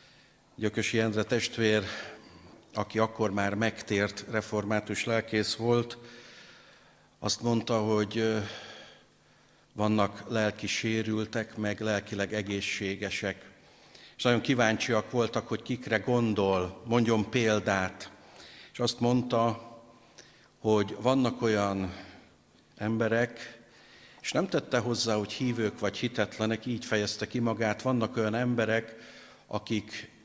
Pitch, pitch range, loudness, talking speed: 110 Hz, 105-115 Hz, -30 LUFS, 100 wpm